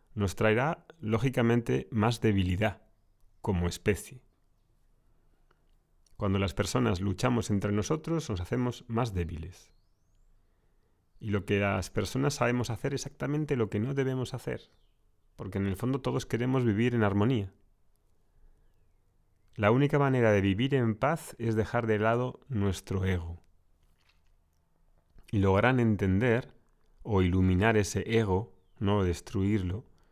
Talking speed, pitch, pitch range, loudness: 125 wpm, 105 Hz, 95-120 Hz, -29 LUFS